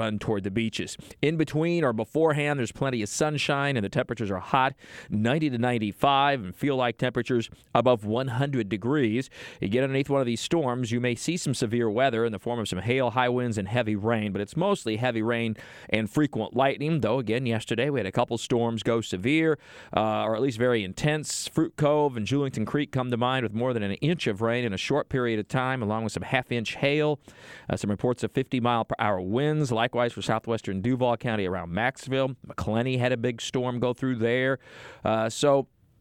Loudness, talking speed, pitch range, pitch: -27 LUFS, 215 wpm, 110-135 Hz, 125 Hz